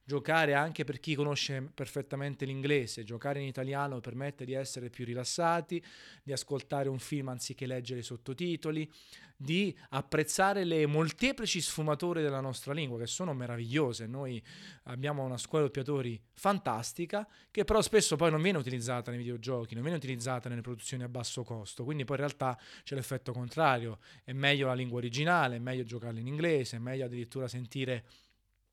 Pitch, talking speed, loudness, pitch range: 135 Hz, 165 wpm, -34 LUFS, 125-155 Hz